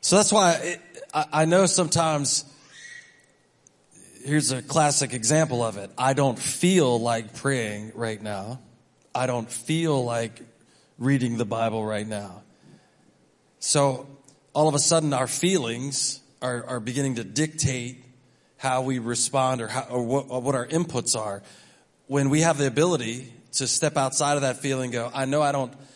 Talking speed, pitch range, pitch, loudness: 160 wpm, 120-150 Hz, 135 Hz, -24 LUFS